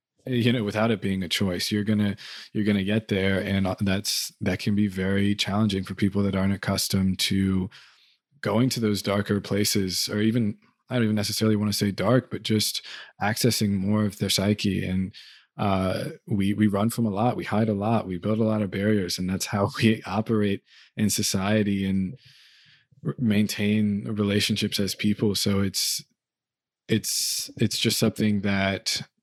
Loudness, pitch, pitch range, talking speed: -25 LUFS, 105 Hz, 100-110 Hz, 175 wpm